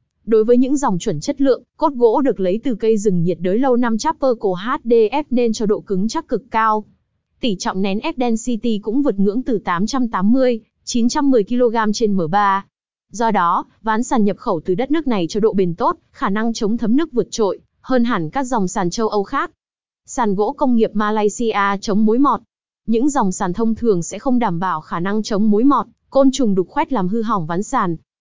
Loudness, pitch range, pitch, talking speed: -18 LUFS, 200-250 Hz, 225 Hz, 215 wpm